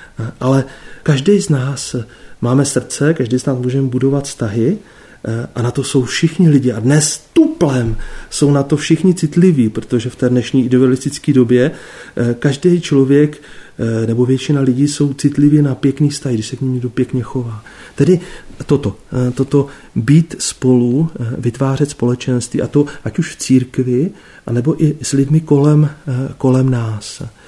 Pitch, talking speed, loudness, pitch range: 135 Hz, 150 wpm, -15 LUFS, 125-145 Hz